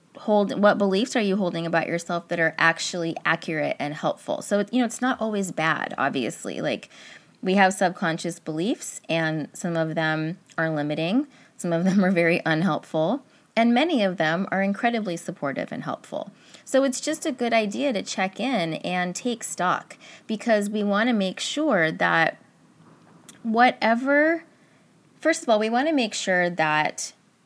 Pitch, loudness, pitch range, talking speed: 195 Hz, -24 LUFS, 165-240 Hz, 170 wpm